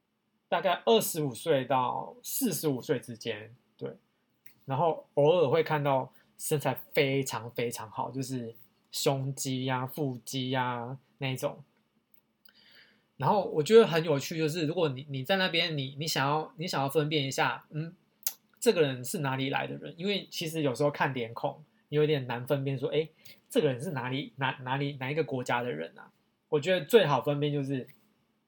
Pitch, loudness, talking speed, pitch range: 145 Hz, -30 LUFS, 260 characters per minute, 130-160 Hz